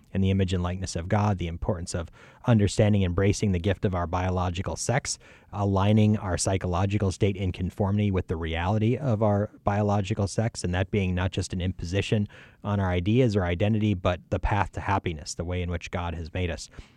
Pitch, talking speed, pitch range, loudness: 95 Hz, 200 wpm, 90-105 Hz, -27 LUFS